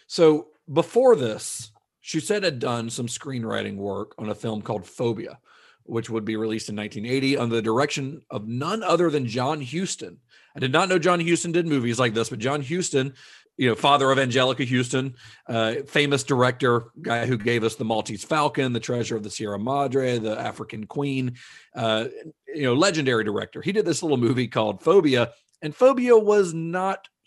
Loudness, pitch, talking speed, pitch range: -23 LUFS, 130 Hz, 185 wpm, 115-155 Hz